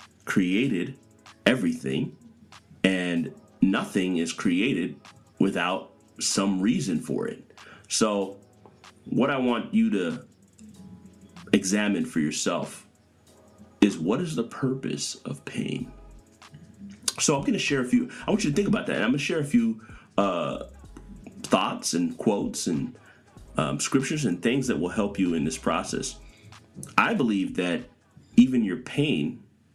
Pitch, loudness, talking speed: 120 Hz, -26 LUFS, 140 wpm